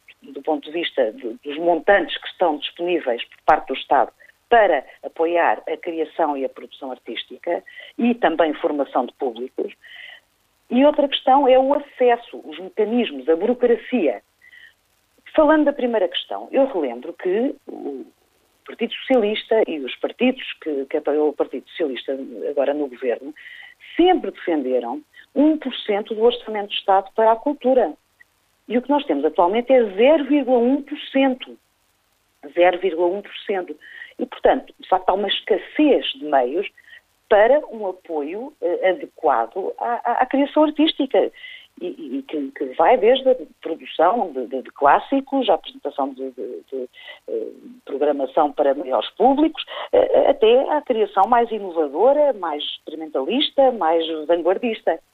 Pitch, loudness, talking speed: 240 Hz, -20 LUFS, 140 wpm